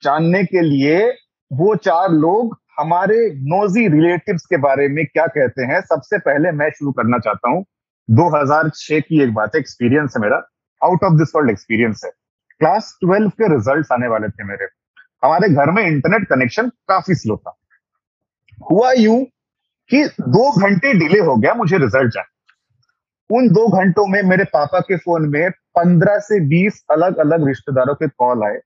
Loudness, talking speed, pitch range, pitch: -15 LUFS, 170 wpm, 140-200 Hz, 165 Hz